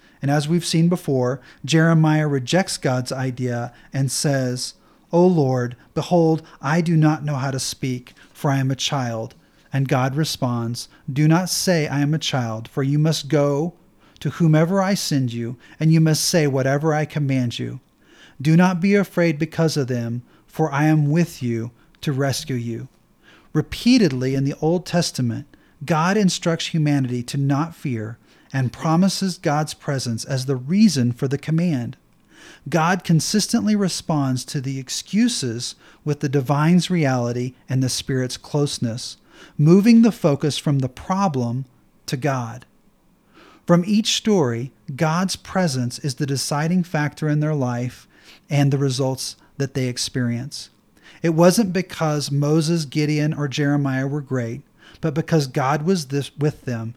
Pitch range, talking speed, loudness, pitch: 130-165 Hz, 155 wpm, -21 LUFS, 145 Hz